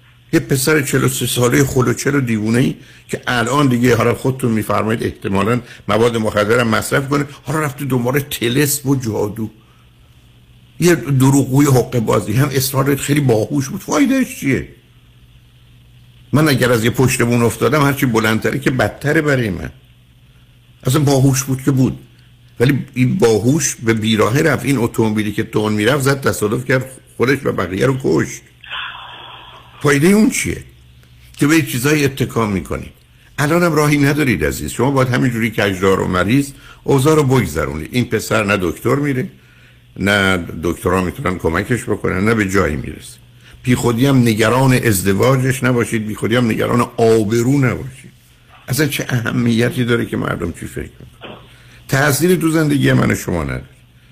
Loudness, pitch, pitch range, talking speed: -16 LUFS, 125 Hz, 110-140 Hz, 150 wpm